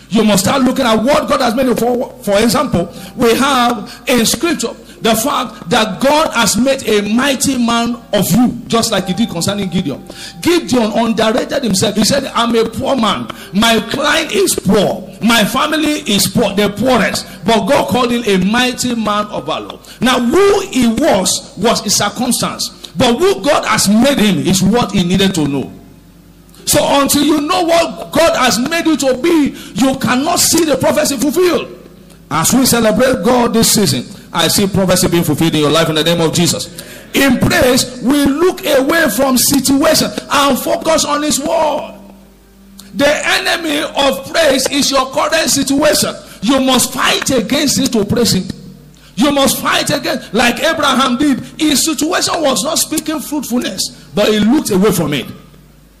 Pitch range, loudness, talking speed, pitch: 210-285 Hz, -12 LUFS, 175 wpm, 250 Hz